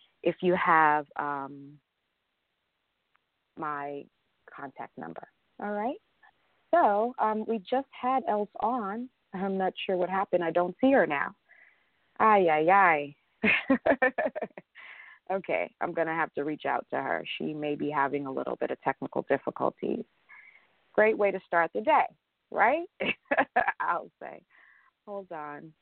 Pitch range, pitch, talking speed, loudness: 150-215 Hz, 180 Hz, 140 wpm, -28 LUFS